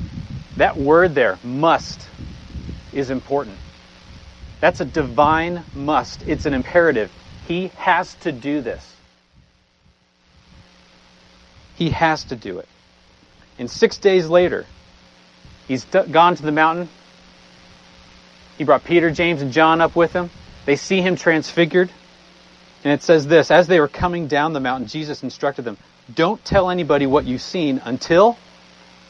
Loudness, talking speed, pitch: -18 LUFS, 140 wpm, 145 Hz